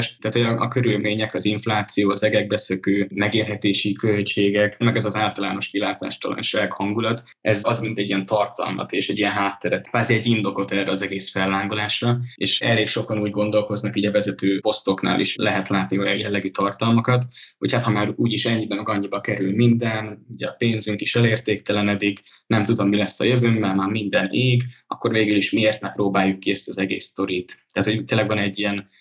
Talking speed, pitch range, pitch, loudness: 190 wpm, 100-110 Hz, 105 Hz, -21 LUFS